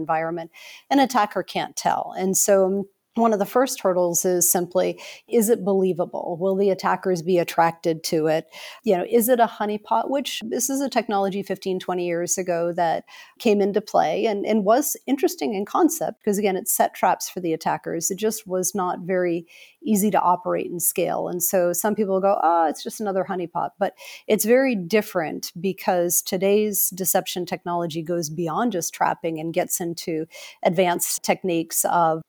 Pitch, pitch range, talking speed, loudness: 190 Hz, 175-210 Hz, 175 wpm, -22 LUFS